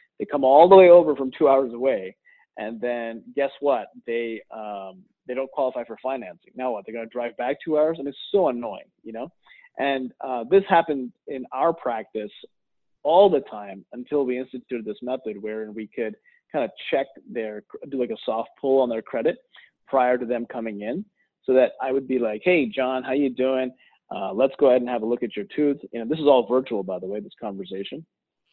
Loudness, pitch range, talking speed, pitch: -23 LUFS, 115-140 Hz, 215 wpm, 130 Hz